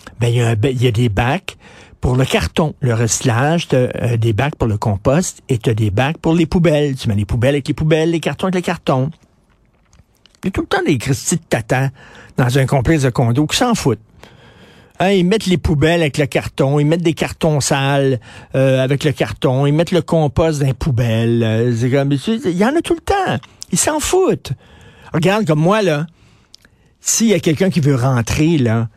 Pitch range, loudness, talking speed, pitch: 125-170 Hz, -16 LUFS, 215 wpm, 140 Hz